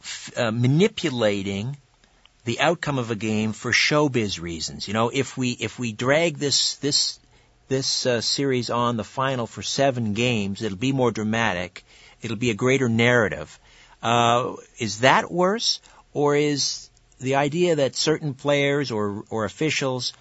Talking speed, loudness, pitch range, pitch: 155 wpm, -23 LUFS, 110-140 Hz, 125 Hz